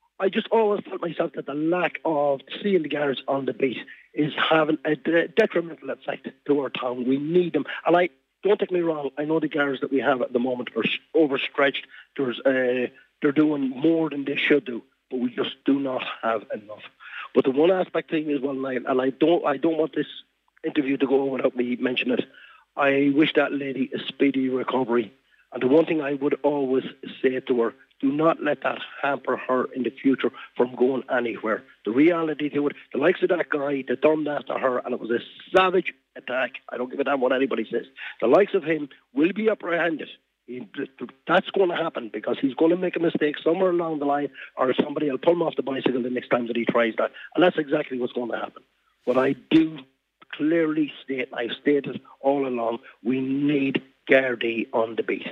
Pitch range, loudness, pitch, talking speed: 130-160 Hz, -24 LUFS, 145 Hz, 215 wpm